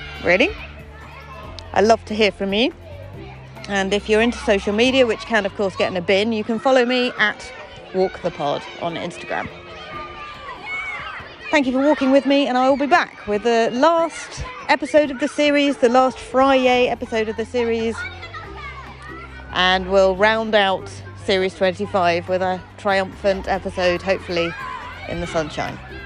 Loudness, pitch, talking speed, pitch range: -19 LUFS, 210 Hz, 160 wpm, 185-250 Hz